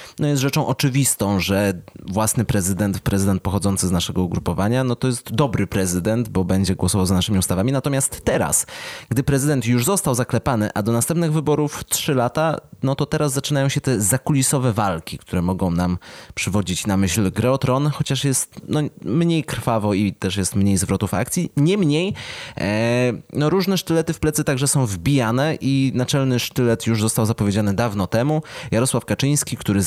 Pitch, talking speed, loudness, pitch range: 120 Hz, 170 wpm, -20 LUFS, 100-140 Hz